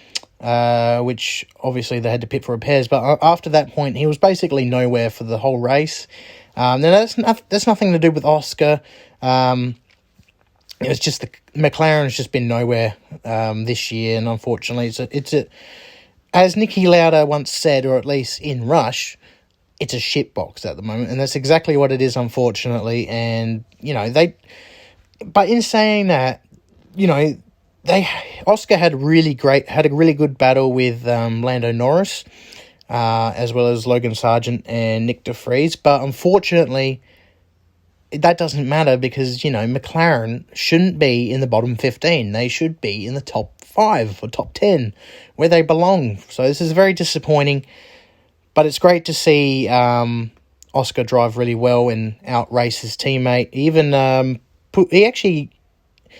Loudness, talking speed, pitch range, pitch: -17 LUFS, 165 wpm, 120-155 Hz, 130 Hz